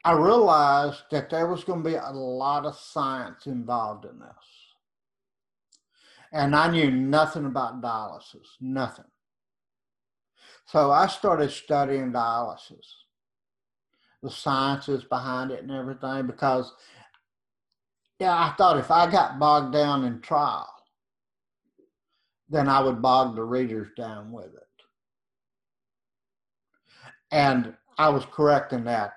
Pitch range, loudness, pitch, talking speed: 125-145 Hz, -24 LUFS, 135 Hz, 120 wpm